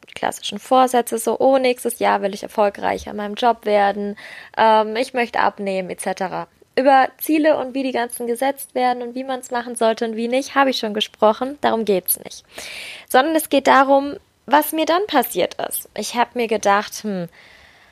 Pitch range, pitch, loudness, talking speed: 215-260 Hz, 240 Hz, -19 LUFS, 190 wpm